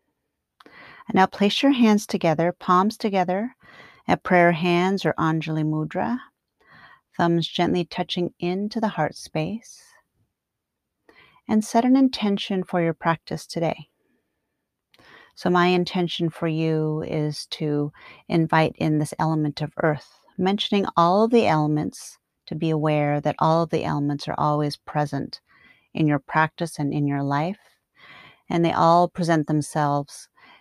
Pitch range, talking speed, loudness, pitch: 155-185 Hz, 135 wpm, -23 LUFS, 170 Hz